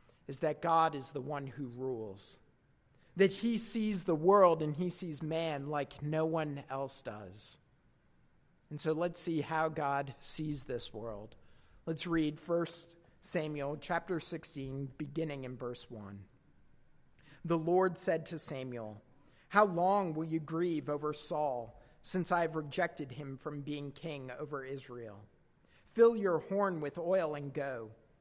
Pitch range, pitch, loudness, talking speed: 135-170 Hz, 150 Hz, -34 LUFS, 145 wpm